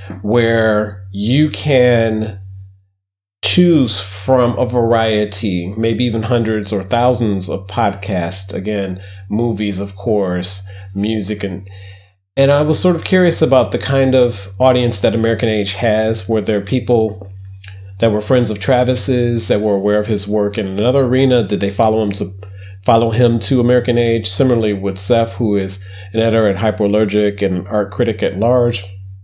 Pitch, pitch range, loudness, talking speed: 105 Hz, 100-120 Hz, -15 LUFS, 155 wpm